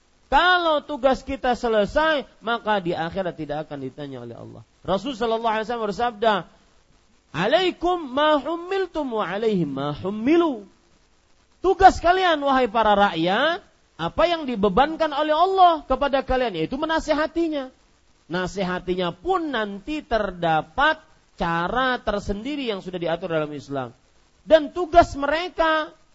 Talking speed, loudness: 105 wpm, -22 LUFS